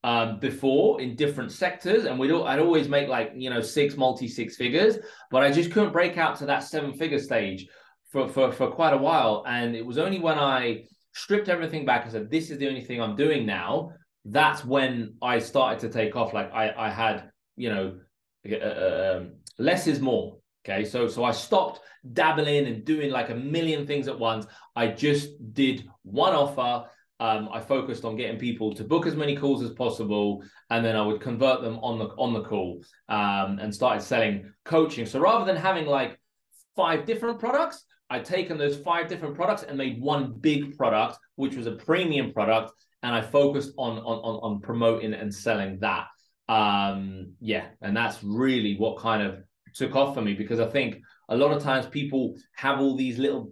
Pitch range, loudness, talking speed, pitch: 110-145 Hz, -26 LUFS, 200 wpm, 130 Hz